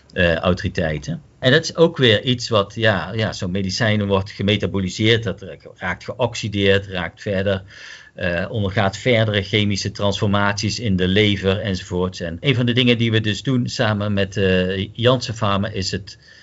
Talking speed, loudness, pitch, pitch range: 160 wpm, -19 LUFS, 100 Hz, 95-115 Hz